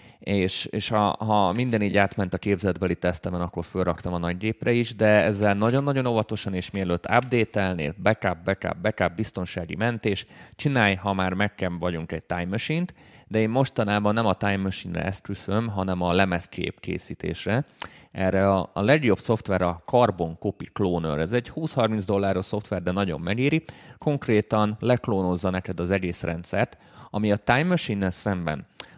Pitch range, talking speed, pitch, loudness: 90-110 Hz, 160 wpm, 100 Hz, -25 LUFS